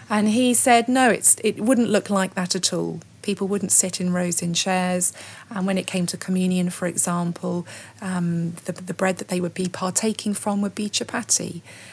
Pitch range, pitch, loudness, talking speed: 180-205 Hz, 185 Hz, -21 LUFS, 200 wpm